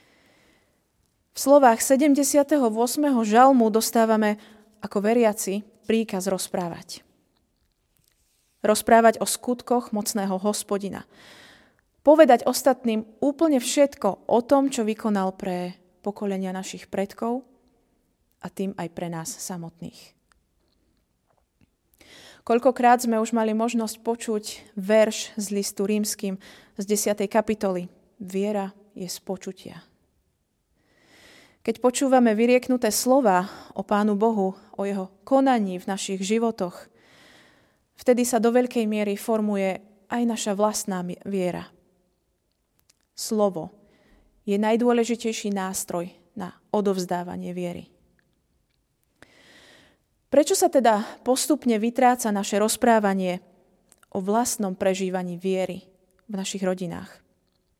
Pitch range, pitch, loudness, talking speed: 190-235 Hz, 210 Hz, -23 LUFS, 95 wpm